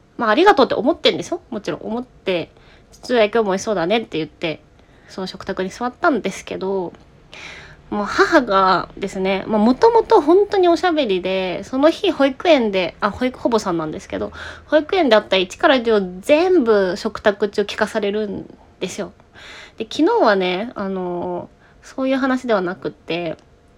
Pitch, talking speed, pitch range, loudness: 215 Hz, 355 characters per minute, 185-295 Hz, -18 LUFS